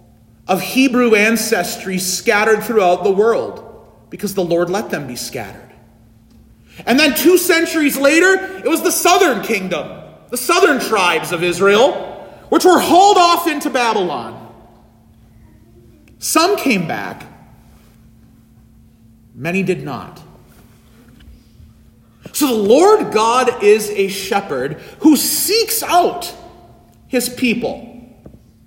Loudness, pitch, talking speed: -14 LUFS, 220 Hz, 110 wpm